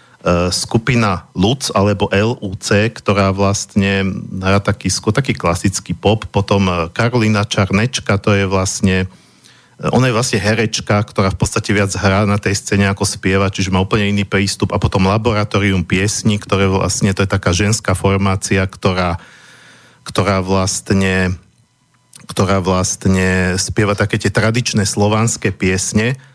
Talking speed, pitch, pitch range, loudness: 130 wpm, 100 Hz, 95-110 Hz, -15 LUFS